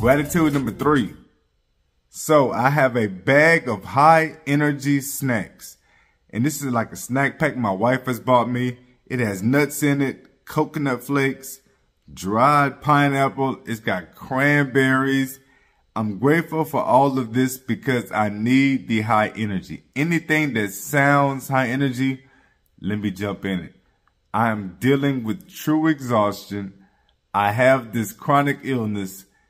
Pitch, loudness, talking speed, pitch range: 130 Hz, -20 LUFS, 140 wpm, 110-140 Hz